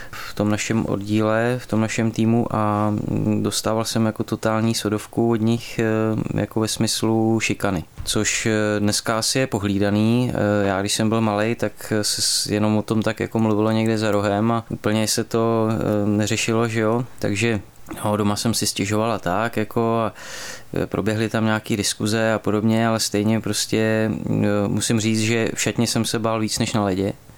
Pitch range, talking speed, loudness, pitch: 105-115 Hz, 170 wpm, -21 LUFS, 110 Hz